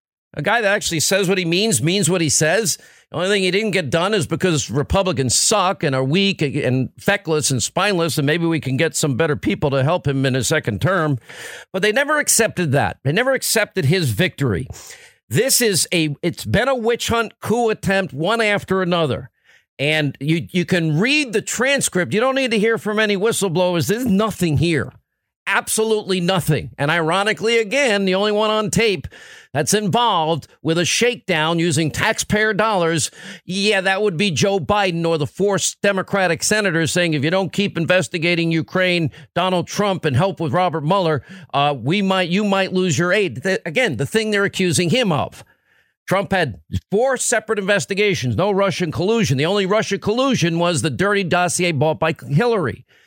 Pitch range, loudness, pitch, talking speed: 155-205 Hz, -18 LUFS, 180 Hz, 185 wpm